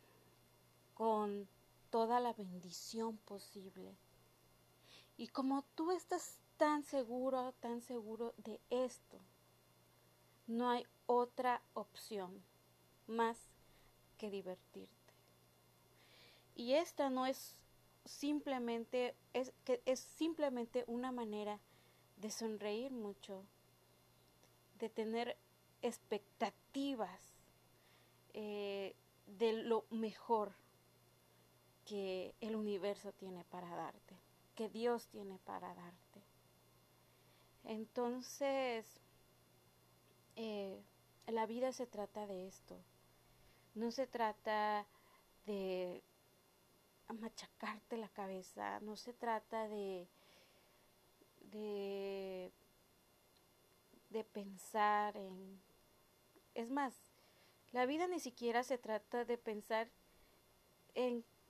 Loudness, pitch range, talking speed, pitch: -43 LUFS, 185-240 Hz, 85 wpm, 215 Hz